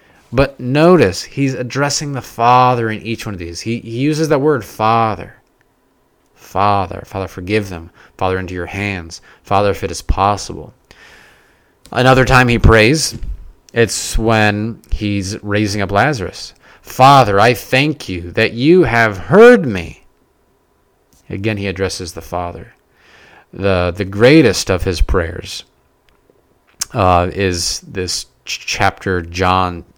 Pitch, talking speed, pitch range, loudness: 105 Hz, 130 wpm, 95-125 Hz, -14 LUFS